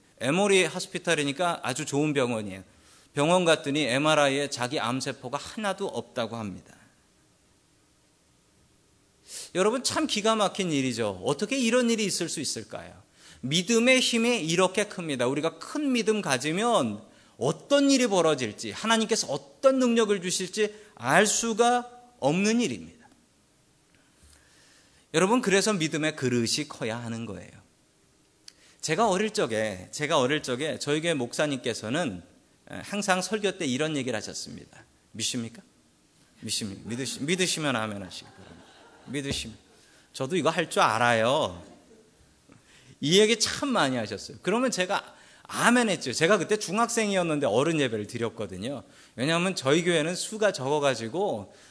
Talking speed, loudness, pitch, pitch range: 295 characters per minute, -26 LUFS, 165 Hz, 135-210 Hz